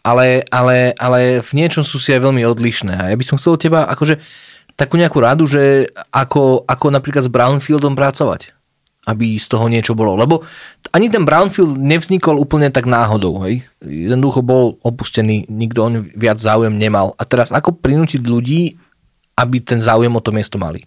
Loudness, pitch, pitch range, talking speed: -13 LUFS, 125 Hz, 115-145 Hz, 180 wpm